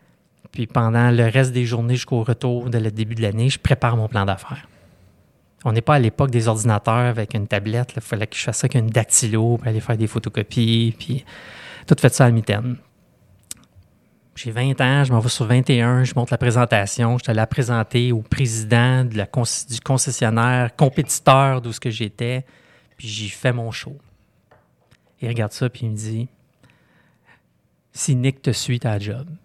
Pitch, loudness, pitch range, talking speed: 120 Hz, -19 LUFS, 110-130 Hz, 195 wpm